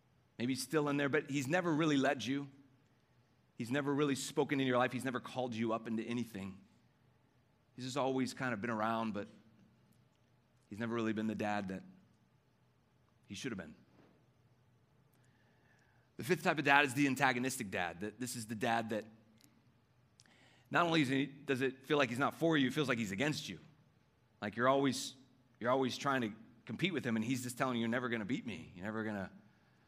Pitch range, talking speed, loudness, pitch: 115-135 Hz, 195 wpm, -36 LUFS, 125 Hz